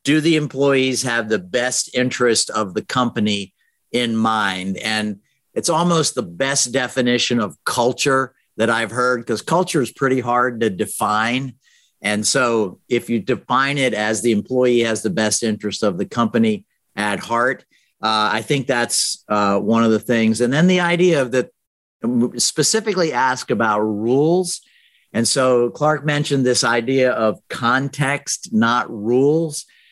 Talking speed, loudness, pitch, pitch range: 155 wpm, -18 LUFS, 125 Hz, 110-140 Hz